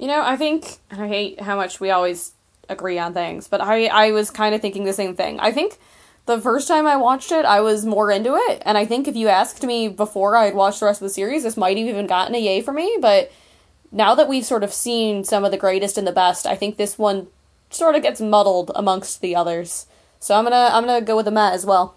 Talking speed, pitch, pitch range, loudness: 260 wpm, 210 Hz, 195-235 Hz, -19 LUFS